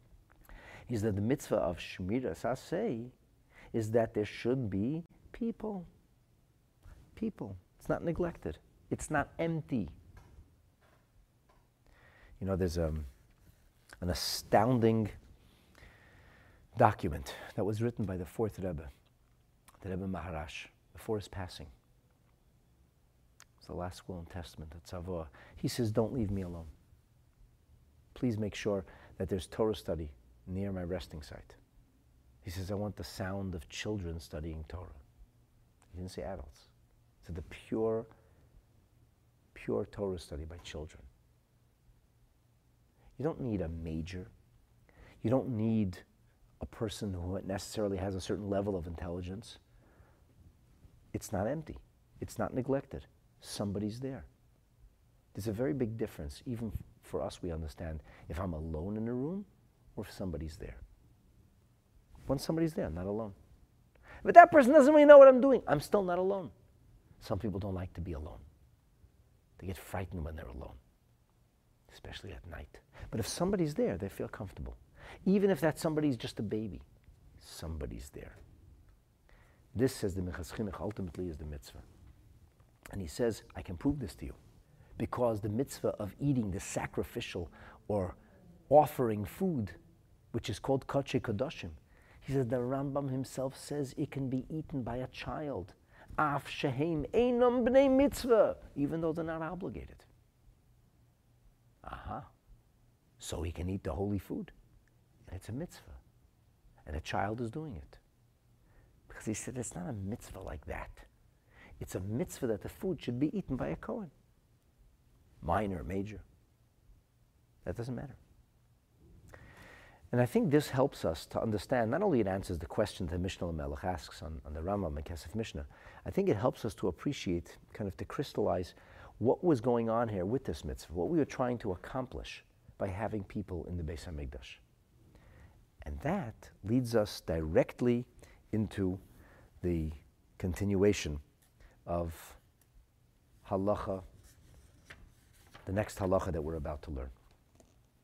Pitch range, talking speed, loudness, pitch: 85-120 Hz, 145 wpm, -33 LUFS, 100 Hz